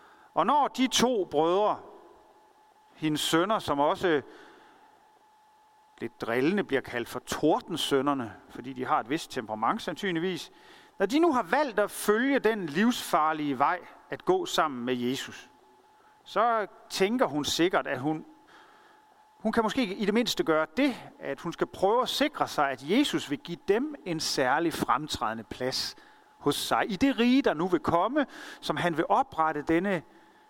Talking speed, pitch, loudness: 160 wpm, 220 Hz, -28 LUFS